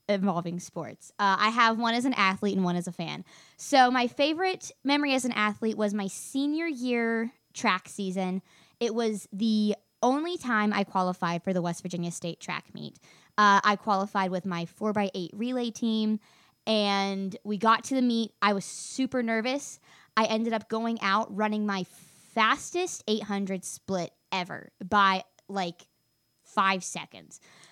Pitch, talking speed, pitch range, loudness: 205 Hz, 165 wpm, 185-230 Hz, -28 LUFS